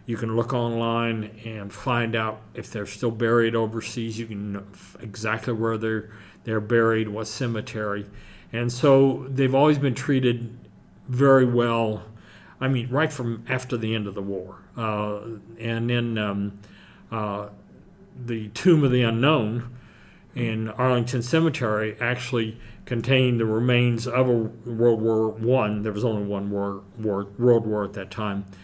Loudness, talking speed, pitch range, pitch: -24 LUFS, 155 wpm, 105-120 Hz, 115 Hz